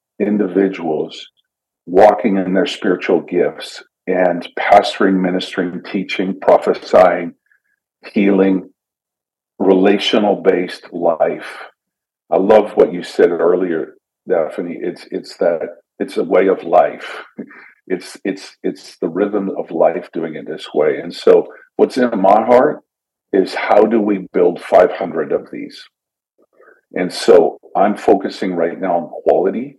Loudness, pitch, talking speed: -15 LUFS, 105 Hz, 125 wpm